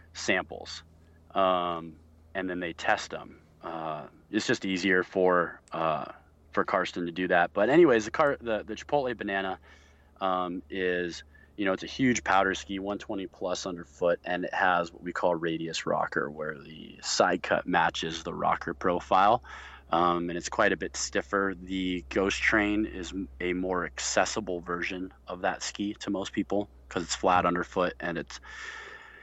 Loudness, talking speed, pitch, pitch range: -29 LUFS, 165 wpm, 90 Hz, 85-95 Hz